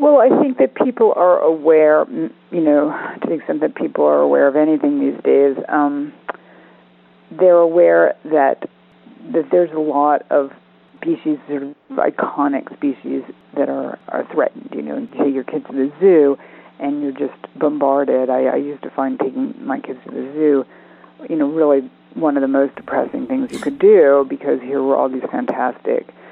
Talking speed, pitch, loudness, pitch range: 180 wpm, 145 Hz, -17 LUFS, 135-160 Hz